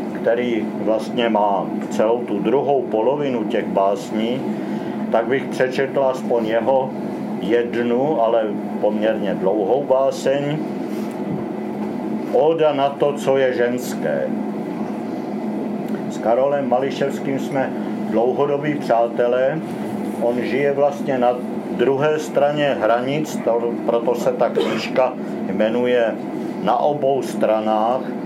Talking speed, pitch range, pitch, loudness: 100 wpm, 115-140 Hz, 120 Hz, -20 LUFS